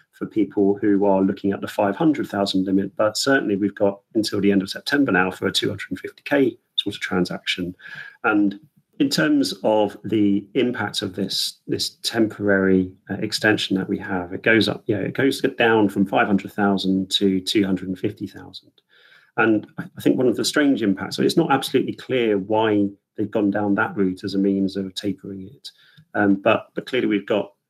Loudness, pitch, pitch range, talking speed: -21 LUFS, 100 Hz, 95-110 Hz, 210 wpm